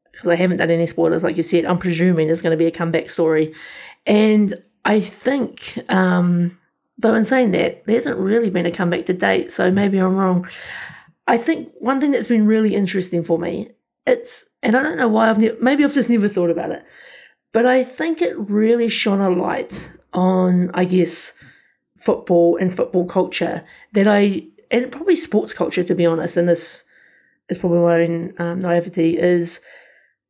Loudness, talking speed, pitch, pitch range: -18 LUFS, 190 wpm, 185 Hz, 170-225 Hz